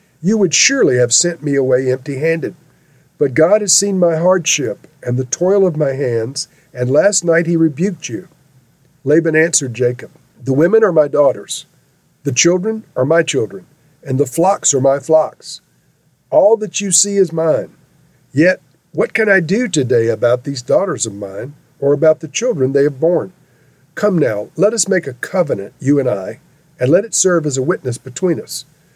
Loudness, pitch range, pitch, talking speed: -15 LUFS, 135-180 Hz, 155 Hz, 180 wpm